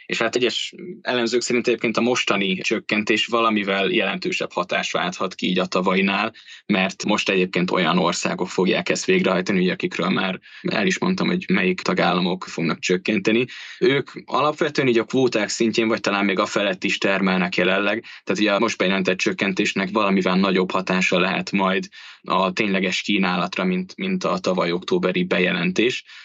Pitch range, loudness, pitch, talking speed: 95-150 Hz, -21 LUFS, 110 Hz, 160 wpm